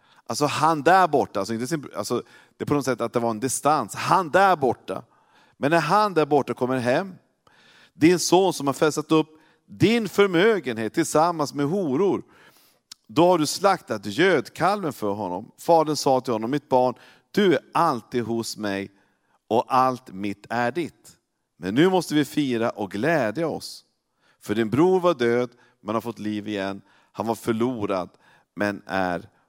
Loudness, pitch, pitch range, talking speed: -23 LUFS, 130 Hz, 115-155 Hz, 165 wpm